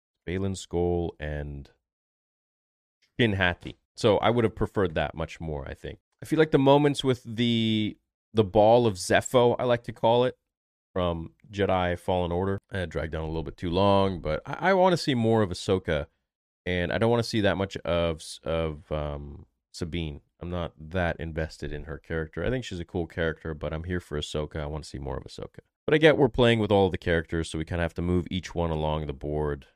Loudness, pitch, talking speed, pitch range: -27 LUFS, 90 Hz, 225 wpm, 80-110 Hz